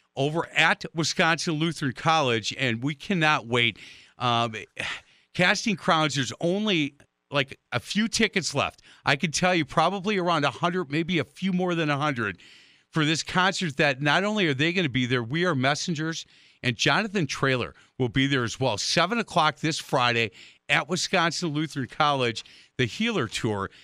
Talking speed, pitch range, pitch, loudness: 170 wpm, 130-175 Hz, 155 Hz, -25 LUFS